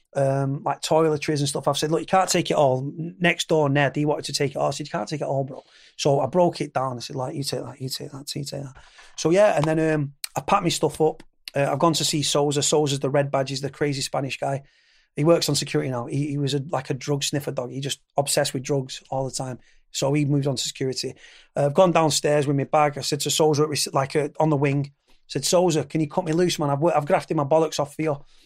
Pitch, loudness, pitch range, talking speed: 145 Hz, -23 LUFS, 140-155 Hz, 280 wpm